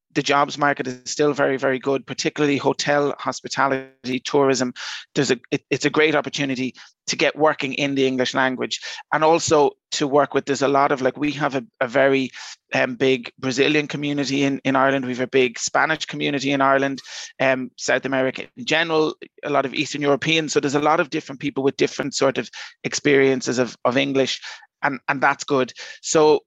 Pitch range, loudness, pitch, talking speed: 135-150 Hz, -21 LUFS, 140 Hz, 195 wpm